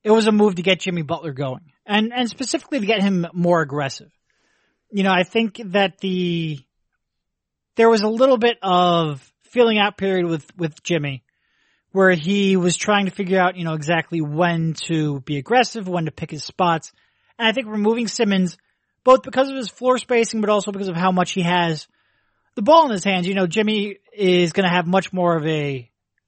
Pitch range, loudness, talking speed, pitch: 170-225 Hz, -19 LUFS, 205 wpm, 190 Hz